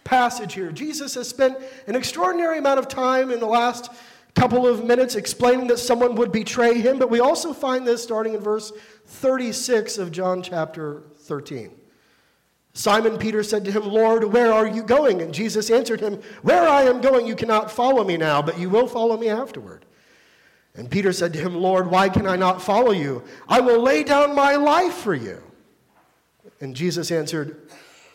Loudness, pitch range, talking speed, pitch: -20 LUFS, 190-250 Hz, 185 wpm, 225 Hz